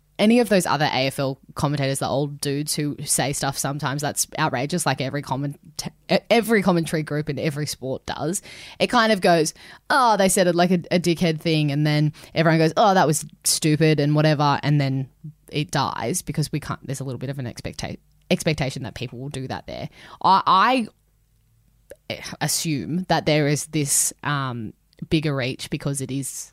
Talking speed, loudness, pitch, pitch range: 185 wpm, -22 LUFS, 150 Hz, 135-165 Hz